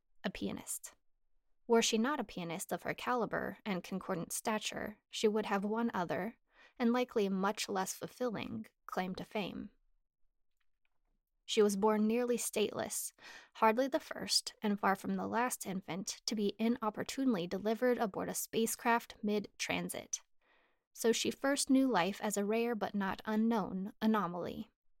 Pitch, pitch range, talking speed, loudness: 220 Hz, 200-235 Hz, 145 wpm, -35 LUFS